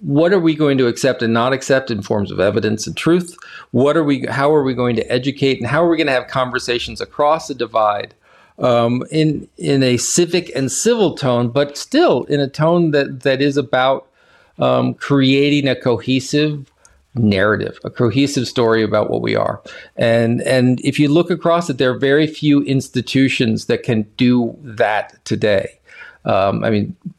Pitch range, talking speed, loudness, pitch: 120-150 Hz, 185 wpm, -16 LUFS, 135 Hz